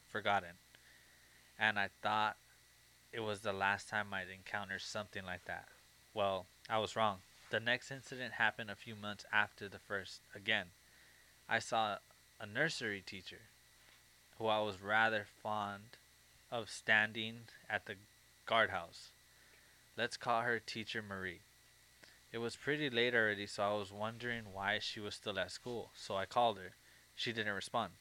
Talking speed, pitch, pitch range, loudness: 150 wpm, 105 Hz, 100-110 Hz, -39 LUFS